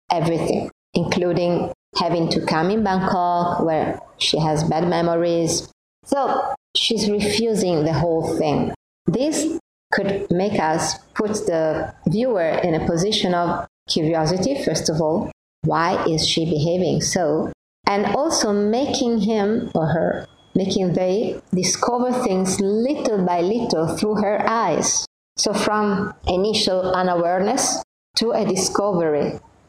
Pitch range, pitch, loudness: 170-215 Hz, 185 Hz, -20 LUFS